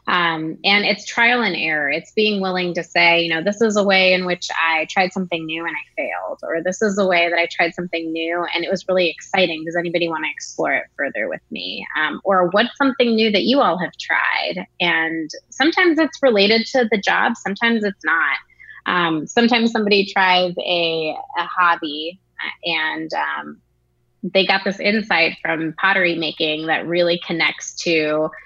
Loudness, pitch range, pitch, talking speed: -18 LUFS, 165-200 Hz, 175 Hz, 190 wpm